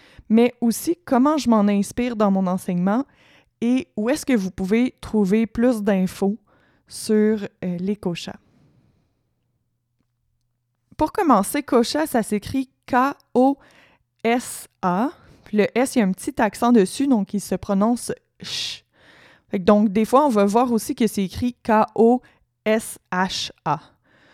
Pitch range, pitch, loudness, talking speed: 200-250 Hz, 220 Hz, -21 LUFS, 130 wpm